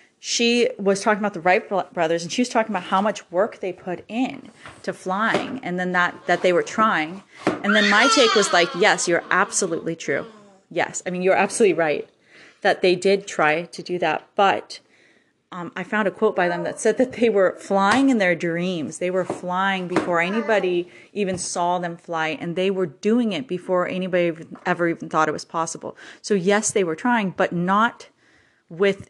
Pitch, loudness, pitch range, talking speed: 185 Hz, -21 LUFS, 175-210 Hz, 200 wpm